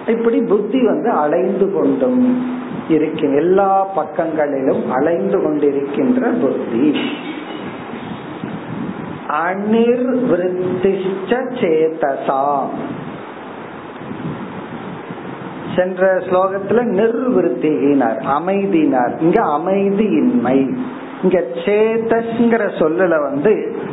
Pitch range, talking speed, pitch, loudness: 170-240 Hz, 55 wpm, 195 Hz, -16 LUFS